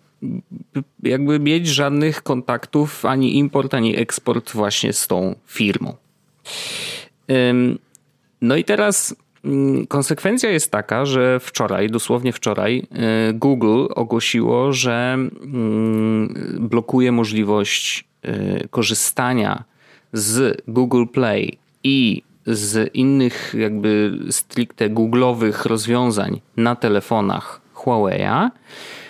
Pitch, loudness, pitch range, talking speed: 125 Hz, -19 LUFS, 110-140 Hz, 85 wpm